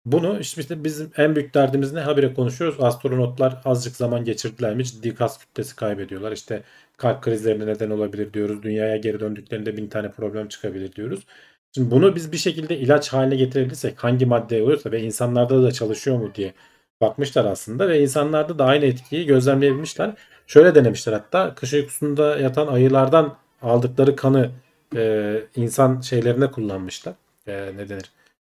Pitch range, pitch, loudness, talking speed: 110-140 Hz, 125 Hz, -21 LUFS, 150 wpm